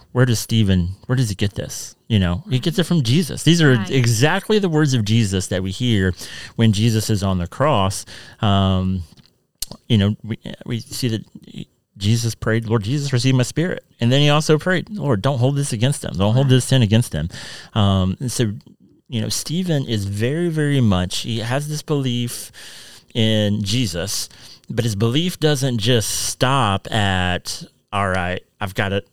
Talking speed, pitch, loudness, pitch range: 185 wpm, 115 Hz, -19 LUFS, 100-135 Hz